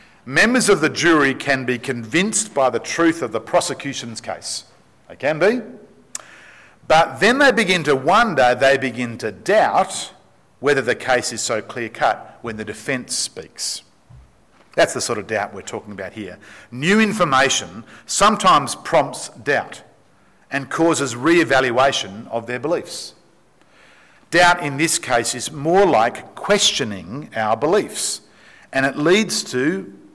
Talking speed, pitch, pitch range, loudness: 145 wpm, 140 Hz, 125-175 Hz, -18 LUFS